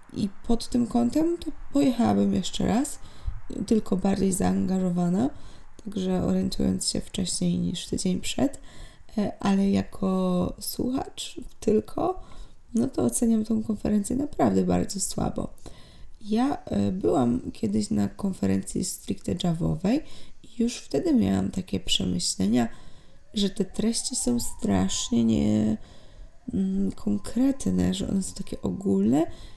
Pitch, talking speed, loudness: 195 Hz, 110 wpm, -26 LUFS